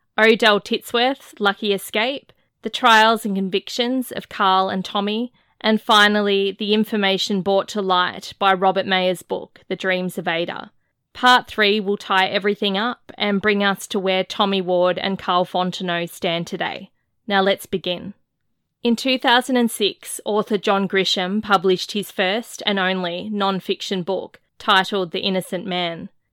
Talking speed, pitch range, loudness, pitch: 150 wpm, 185-215 Hz, -19 LUFS, 195 Hz